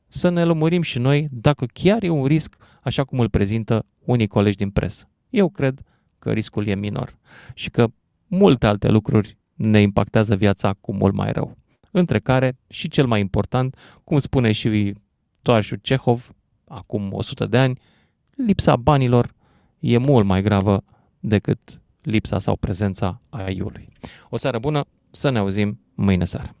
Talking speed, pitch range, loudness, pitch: 160 wpm, 100-135 Hz, -20 LUFS, 115 Hz